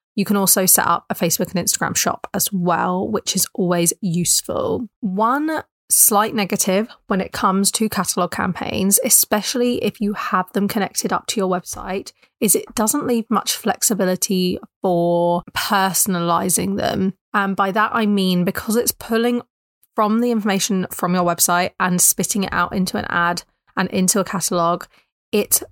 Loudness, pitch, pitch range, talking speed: -18 LUFS, 195 Hz, 180-215 Hz, 165 wpm